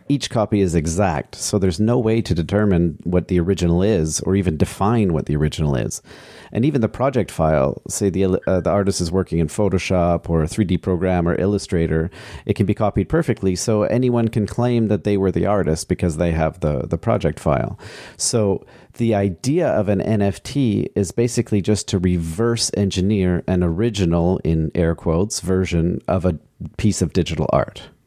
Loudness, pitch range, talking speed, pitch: -19 LUFS, 85-105 Hz, 185 wpm, 95 Hz